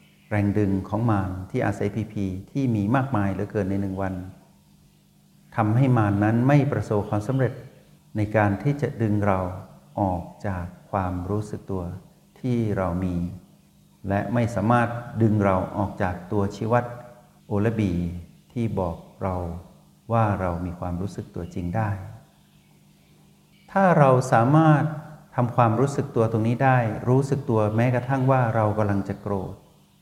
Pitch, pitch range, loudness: 110 Hz, 100-130 Hz, -24 LUFS